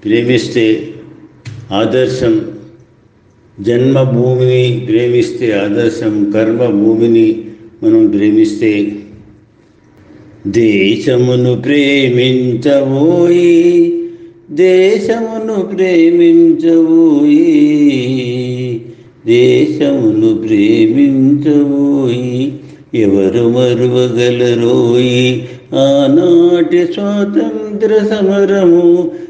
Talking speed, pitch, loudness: 35 wpm, 145 Hz, -10 LUFS